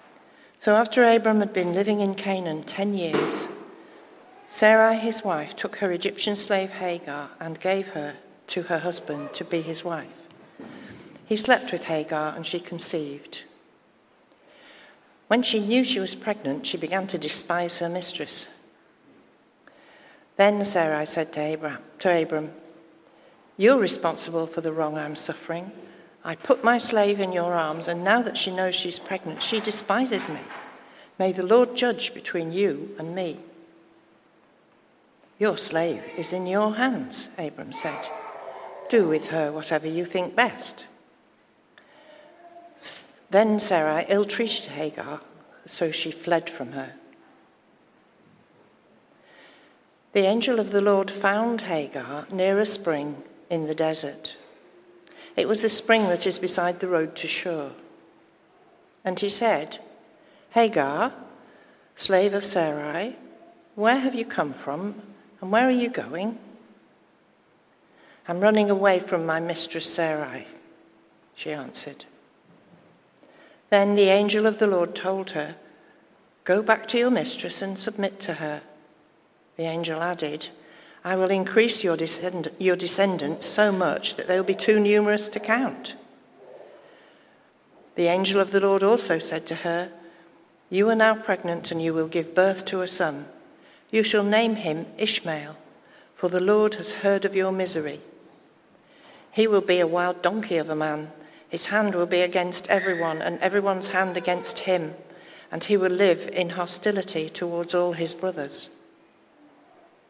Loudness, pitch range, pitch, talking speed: -24 LUFS, 165-210 Hz, 185 Hz, 140 wpm